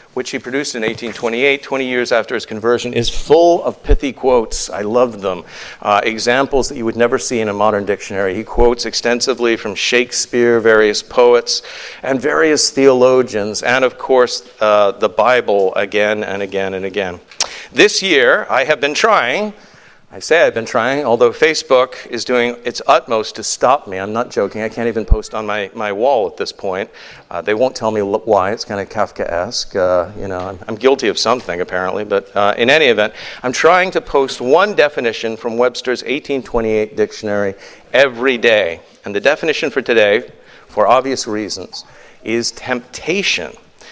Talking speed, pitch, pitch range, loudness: 180 wpm, 120 Hz, 105-130 Hz, -15 LUFS